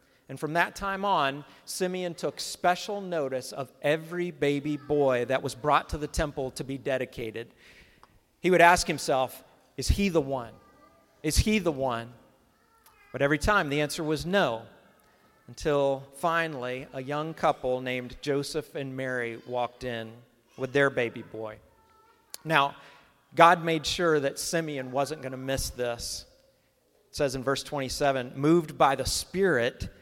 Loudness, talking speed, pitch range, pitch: -28 LUFS, 150 wpm, 130-160 Hz, 140 Hz